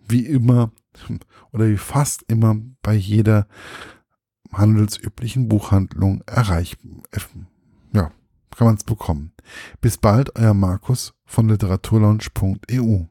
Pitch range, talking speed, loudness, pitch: 100-115 Hz, 100 wpm, -19 LUFS, 110 Hz